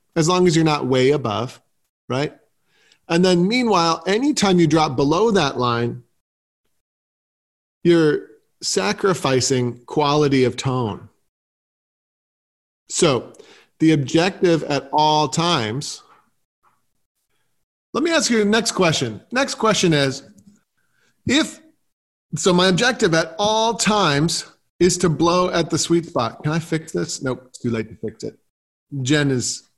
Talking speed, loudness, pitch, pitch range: 130 wpm, -19 LUFS, 160 Hz, 130-190 Hz